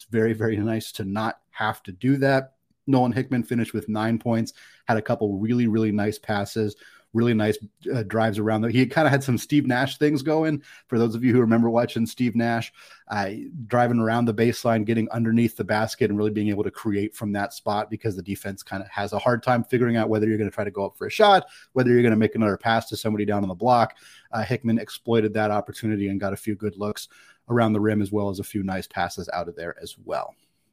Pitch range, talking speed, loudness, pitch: 105-120 Hz, 245 wpm, -24 LUFS, 110 Hz